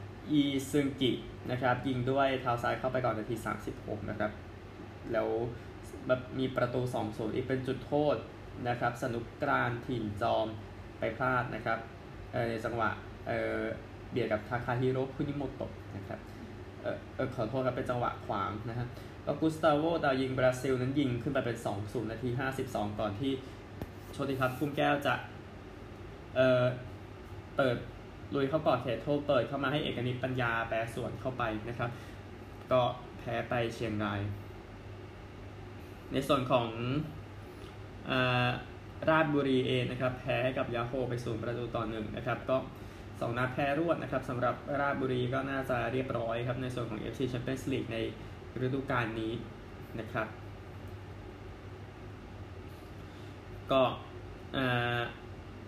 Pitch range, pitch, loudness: 105-130 Hz, 115 Hz, -33 LUFS